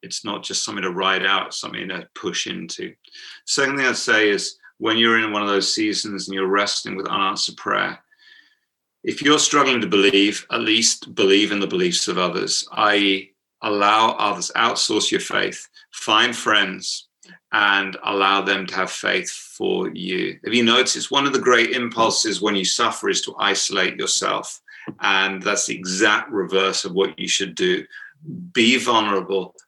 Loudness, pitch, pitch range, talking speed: -19 LUFS, 105 Hz, 100-140 Hz, 170 wpm